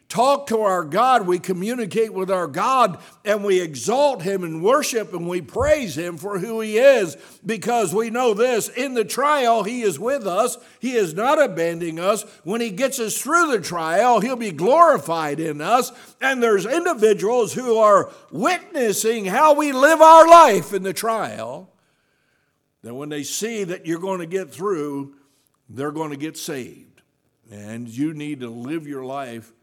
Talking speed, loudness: 175 wpm, -19 LUFS